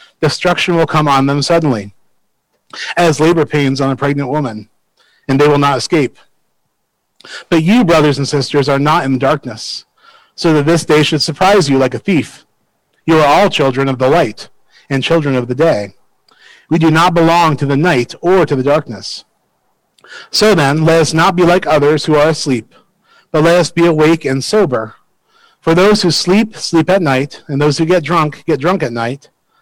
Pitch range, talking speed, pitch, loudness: 140-175 Hz, 190 wpm, 155 Hz, -12 LUFS